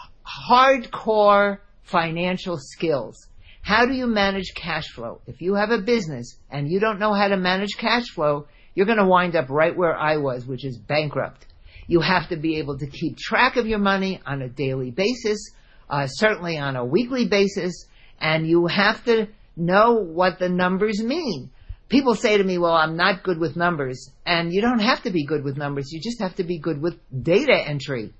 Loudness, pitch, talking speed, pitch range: -21 LUFS, 175 Hz, 200 wpm, 145-210 Hz